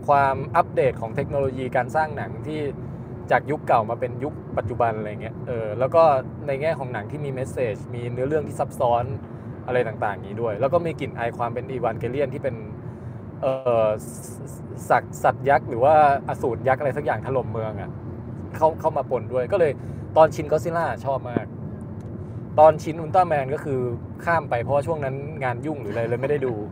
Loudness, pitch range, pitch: -23 LUFS, 115-140 Hz, 125 Hz